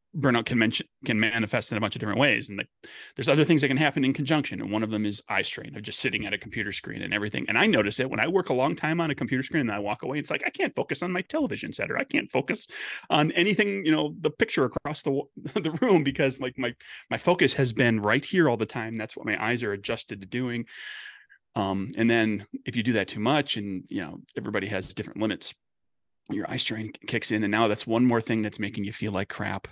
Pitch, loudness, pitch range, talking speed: 120 Hz, -26 LUFS, 110-145 Hz, 265 wpm